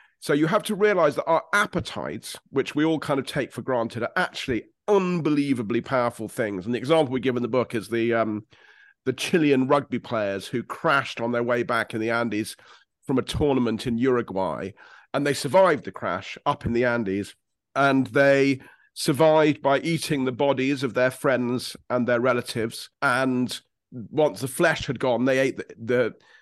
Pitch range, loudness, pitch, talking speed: 120-145 Hz, -24 LUFS, 130 Hz, 185 wpm